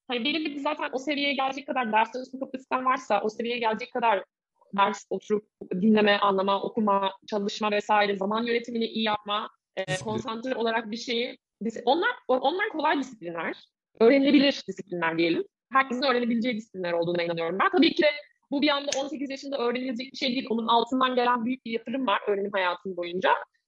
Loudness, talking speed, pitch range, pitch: -26 LUFS, 165 wpm, 205-270 Hz, 240 Hz